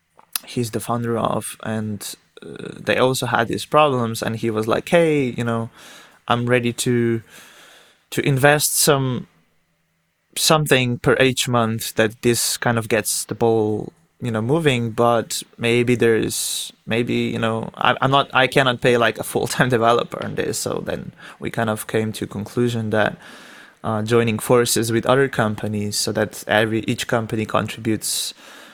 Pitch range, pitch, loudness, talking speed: 110-130 Hz, 120 Hz, -20 LUFS, 165 wpm